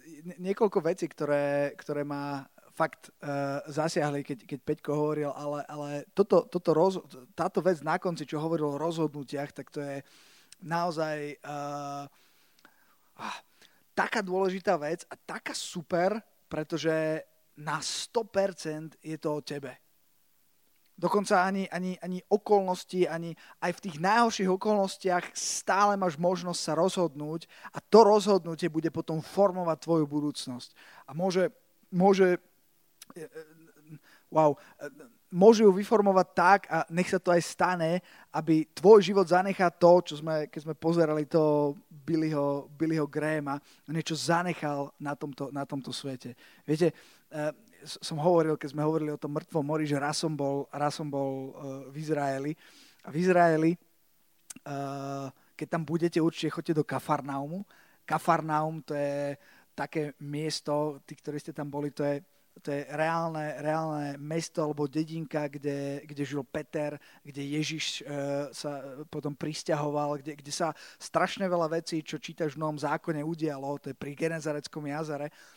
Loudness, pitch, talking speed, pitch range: -29 LUFS, 155 Hz, 140 wpm, 145-175 Hz